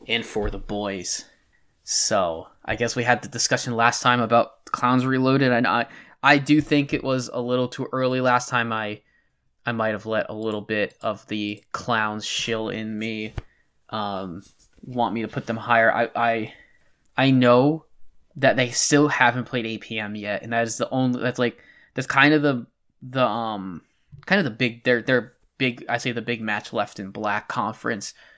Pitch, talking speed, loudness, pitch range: 120 Hz, 190 wpm, -23 LUFS, 110-130 Hz